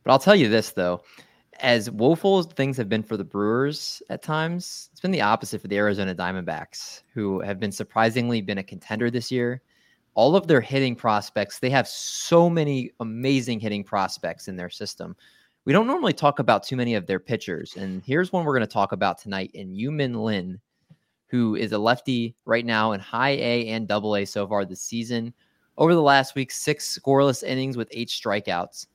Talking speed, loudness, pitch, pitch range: 200 wpm, -24 LUFS, 120 Hz, 105-140 Hz